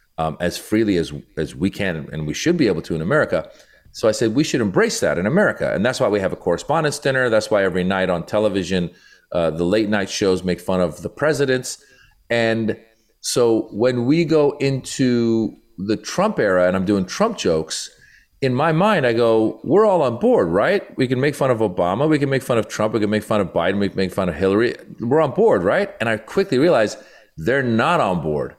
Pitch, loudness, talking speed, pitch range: 105 Hz, -19 LUFS, 225 wpm, 90-125 Hz